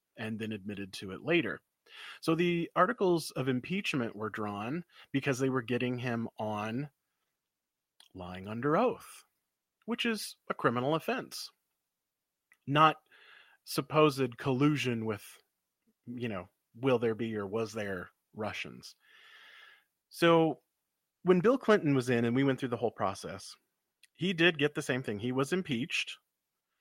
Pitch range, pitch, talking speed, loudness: 115-175 Hz, 135 Hz, 140 wpm, -32 LUFS